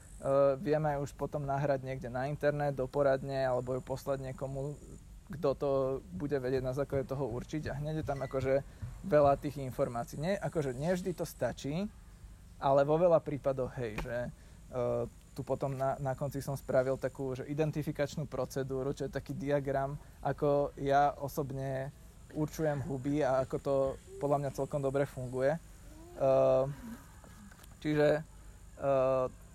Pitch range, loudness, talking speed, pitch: 130-145 Hz, -34 LUFS, 150 wpm, 135 Hz